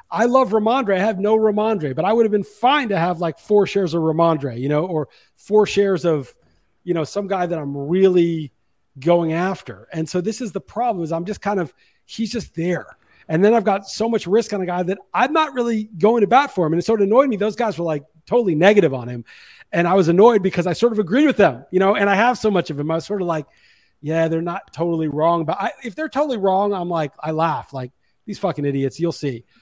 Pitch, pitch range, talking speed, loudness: 185 Hz, 160-215 Hz, 260 wpm, -19 LUFS